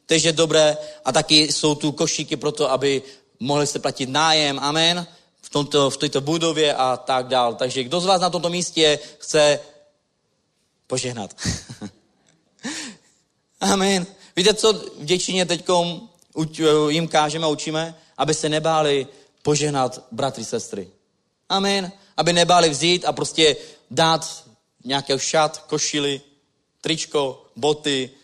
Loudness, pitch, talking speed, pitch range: -20 LUFS, 150 Hz, 125 wpm, 145-165 Hz